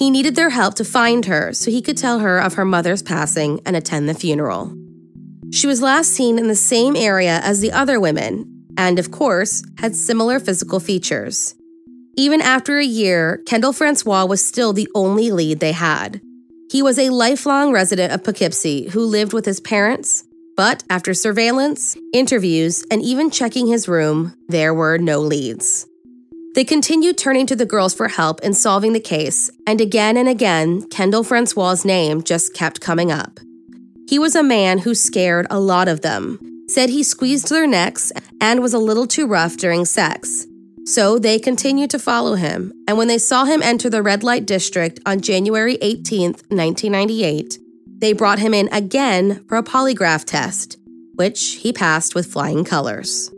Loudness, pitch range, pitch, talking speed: -16 LUFS, 175-250 Hz, 210 Hz, 180 wpm